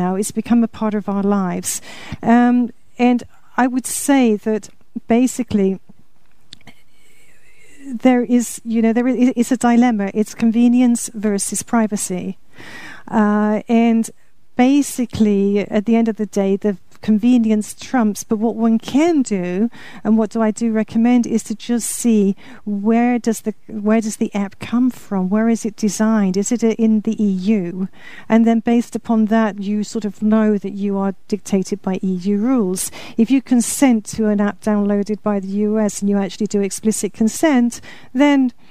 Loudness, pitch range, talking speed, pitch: -17 LUFS, 205-235 Hz, 165 wpm, 220 Hz